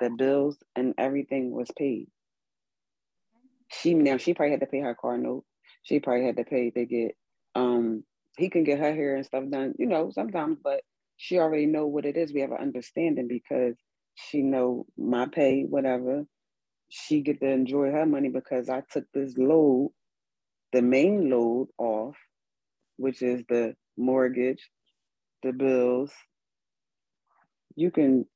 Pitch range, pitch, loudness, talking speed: 125-145 Hz, 135 Hz, -27 LUFS, 160 wpm